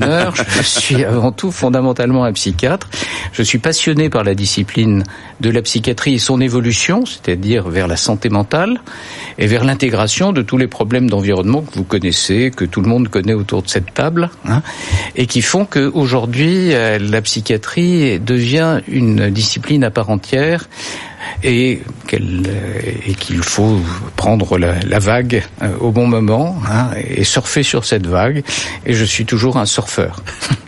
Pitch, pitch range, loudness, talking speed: 120 Hz, 100-130 Hz, -14 LUFS, 155 wpm